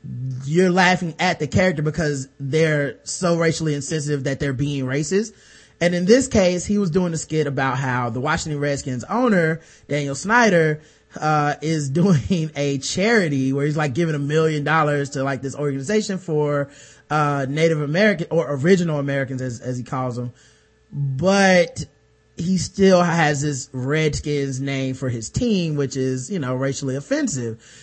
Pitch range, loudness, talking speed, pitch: 135-175 Hz, -20 LUFS, 160 wpm, 150 Hz